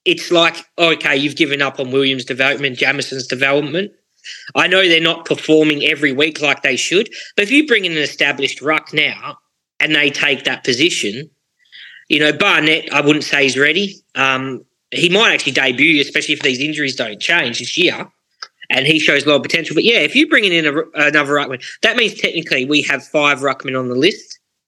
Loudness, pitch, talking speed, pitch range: -14 LUFS, 150 Hz, 200 wpm, 135-165 Hz